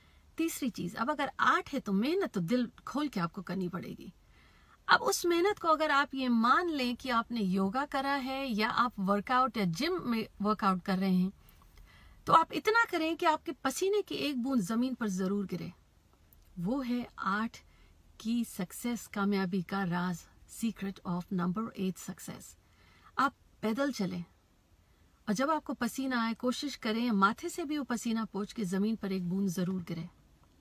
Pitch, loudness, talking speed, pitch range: 225 Hz, -32 LUFS, 175 wpm, 190-270 Hz